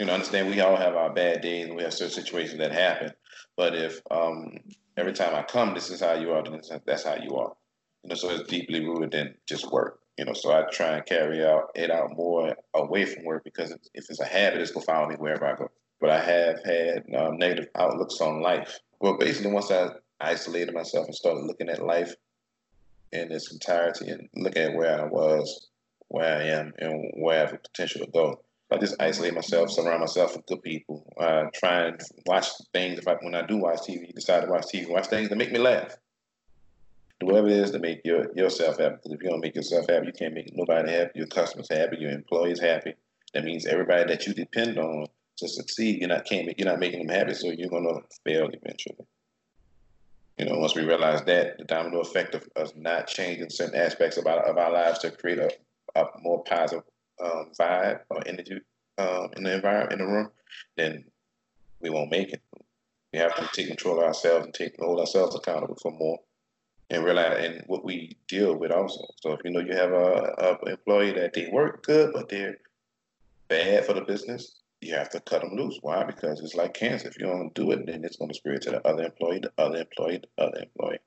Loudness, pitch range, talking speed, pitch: -27 LUFS, 80-110 Hz, 225 wpm, 85 Hz